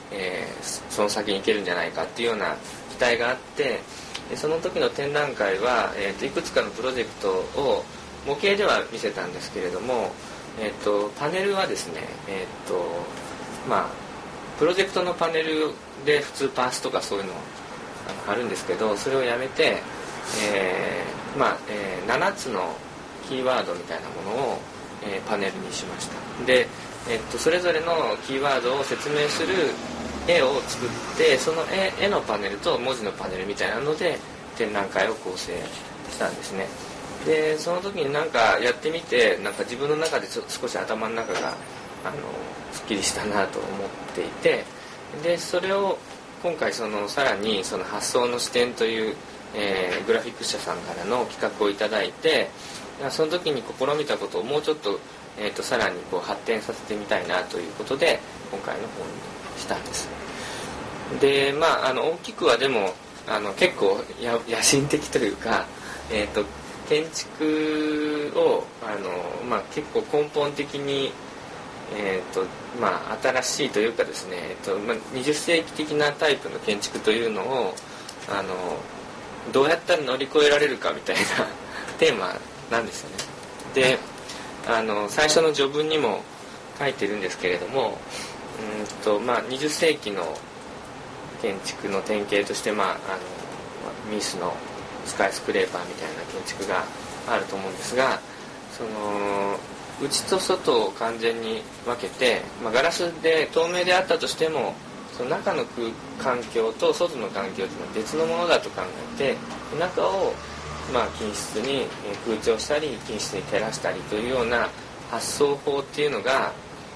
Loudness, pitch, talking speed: -25 LUFS, 155 Hz, 305 characters per minute